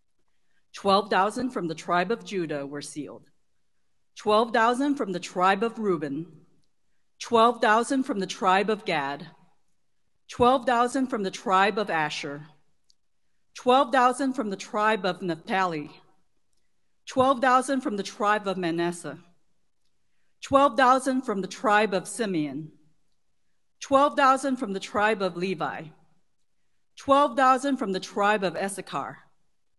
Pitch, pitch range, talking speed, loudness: 195 Hz, 175-250 Hz, 115 wpm, -25 LUFS